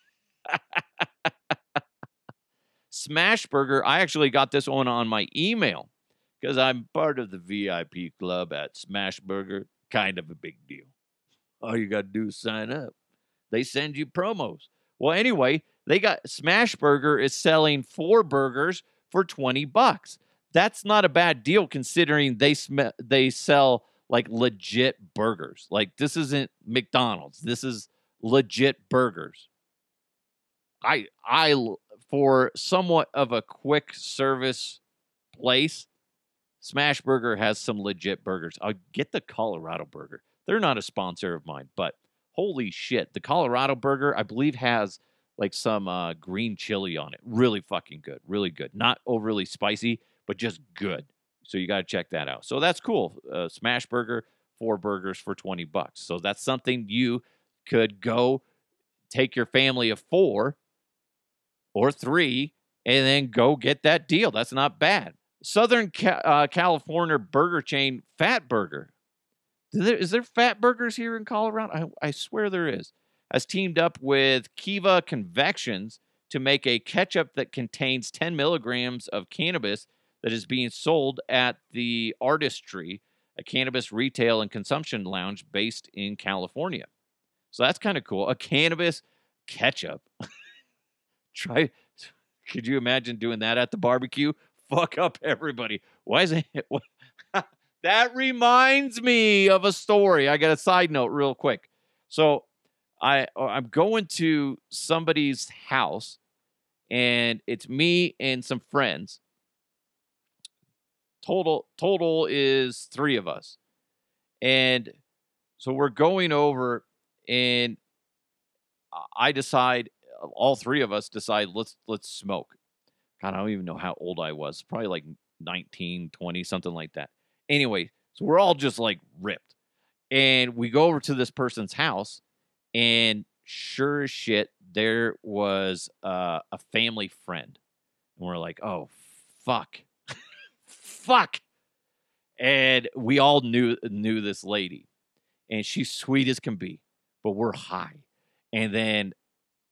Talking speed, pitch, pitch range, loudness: 140 wpm, 130 Hz, 110-150 Hz, -25 LUFS